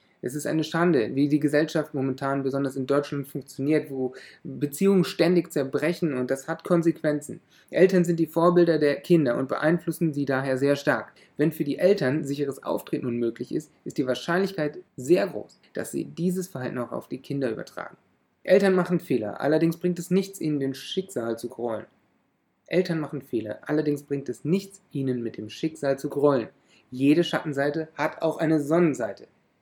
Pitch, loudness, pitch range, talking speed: 150 Hz, -25 LUFS, 135-170 Hz, 170 wpm